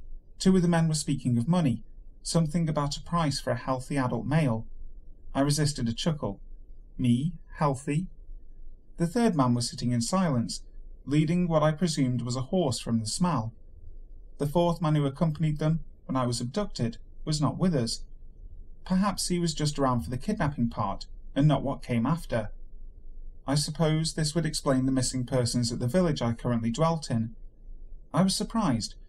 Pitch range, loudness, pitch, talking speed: 115-160 Hz, -28 LUFS, 135 Hz, 175 wpm